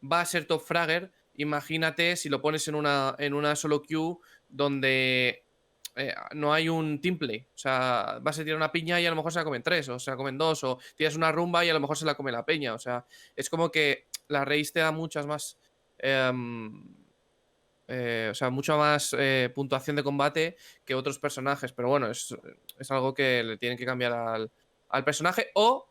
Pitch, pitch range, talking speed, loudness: 145 Hz, 130-160 Hz, 215 wpm, -28 LUFS